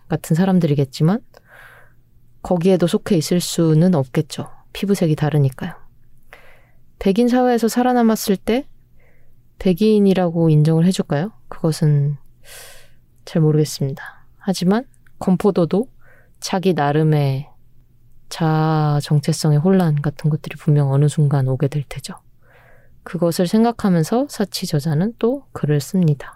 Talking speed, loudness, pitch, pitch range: 275 characters per minute, -18 LUFS, 160 Hz, 145-190 Hz